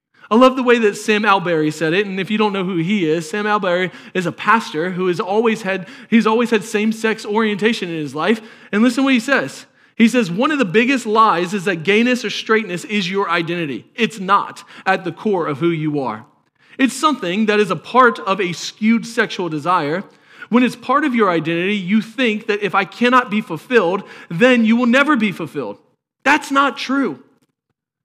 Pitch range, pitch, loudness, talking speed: 185-240 Hz, 210 Hz, -17 LUFS, 210 wpm